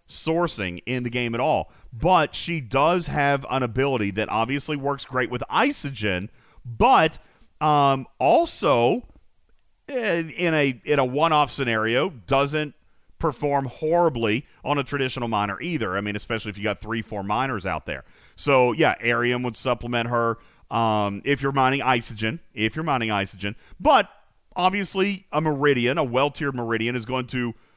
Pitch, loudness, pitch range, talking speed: 130 Hz, -23 LUFS, 115-145 Hz, 155 wpm